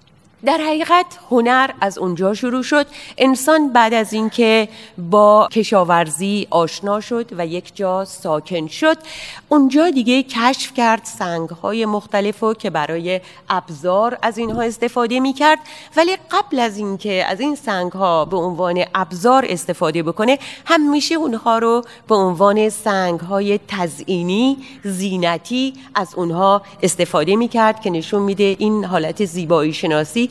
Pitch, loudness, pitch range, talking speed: 210 Hz, -17 LUFS, 185-250 Hz, 140 wpm